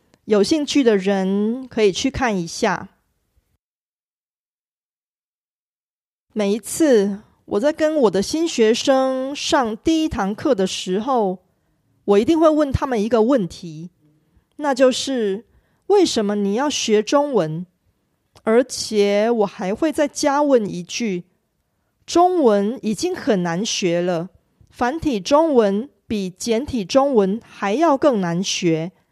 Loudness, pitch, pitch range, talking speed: -19 LUFS, 220 Hz, 195-280 Hz, 175 characters per minute